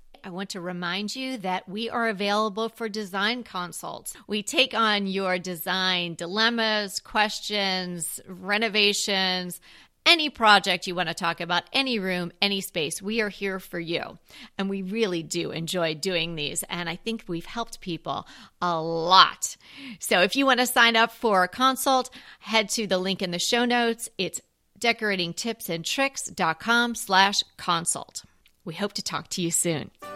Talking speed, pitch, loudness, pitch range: 160 wpm, 195 Hz, -24 LUFS, 180-225 Hz